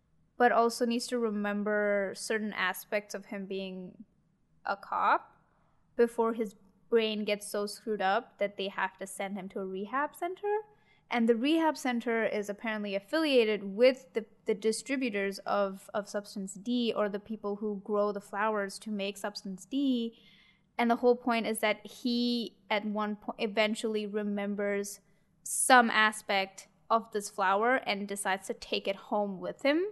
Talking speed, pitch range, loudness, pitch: 160 wpm, 200-235 Hz, -31 LUFS, 210 Hz